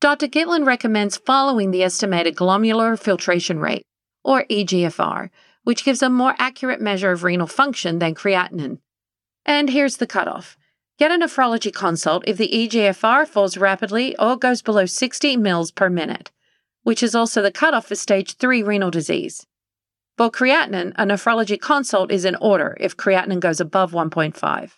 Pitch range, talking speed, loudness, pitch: 185-255 Hz, 155 wpm, -19 LUFS, 210 Hz